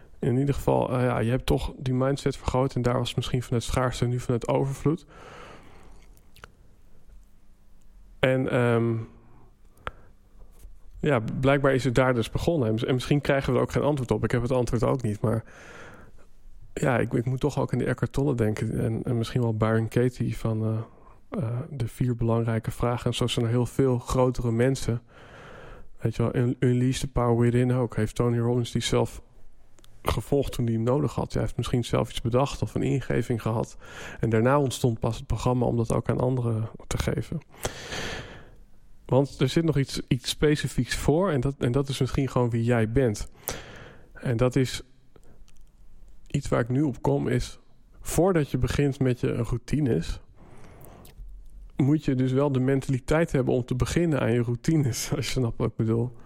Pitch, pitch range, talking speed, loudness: 125 Hz, 115-135 Hz, 185 wpm, -26 LUFS